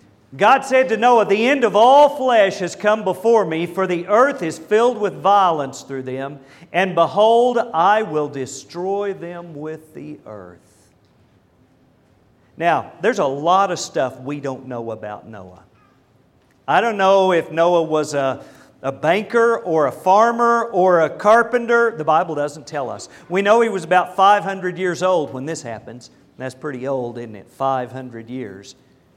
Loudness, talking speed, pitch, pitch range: -17 LUFS, 165 wpm, 170 Hz, 135-210 Hz